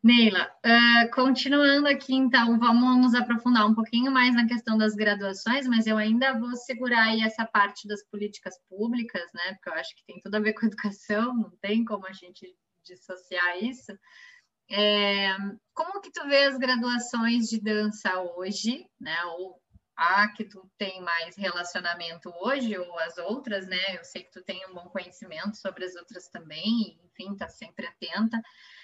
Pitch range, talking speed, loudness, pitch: 185-235 Hz, 175 wpm, -25 LUFS, 210 Hz